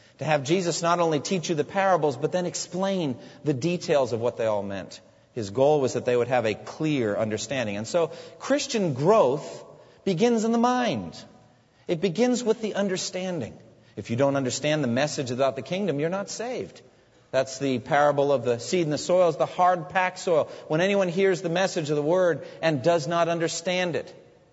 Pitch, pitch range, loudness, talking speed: 165 Hz, 135-185 Hz, -25 LUFS, 195 wpm